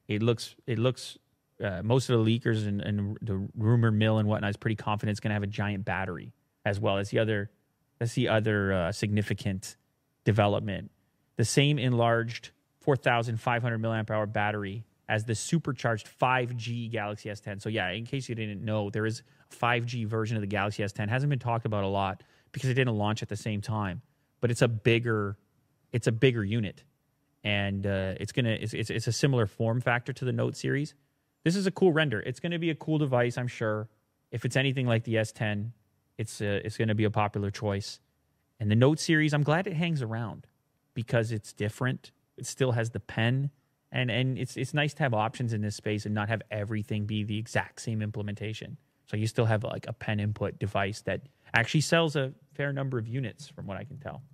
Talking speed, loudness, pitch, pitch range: 210 wpm, -29 LUFS, 115 Hz, 105-130 Hz